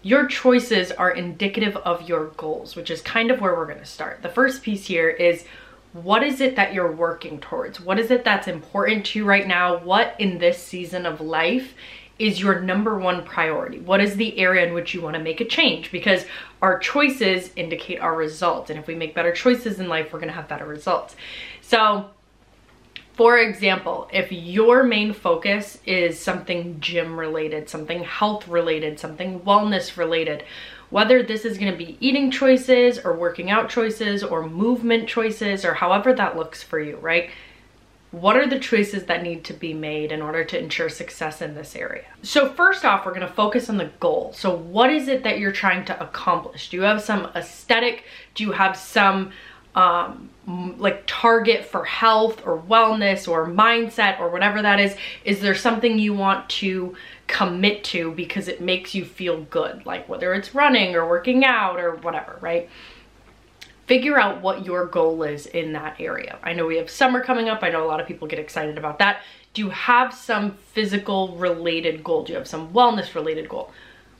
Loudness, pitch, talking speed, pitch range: -21 LUFS, 190 Hz, 195 wpm, 170-220 Hz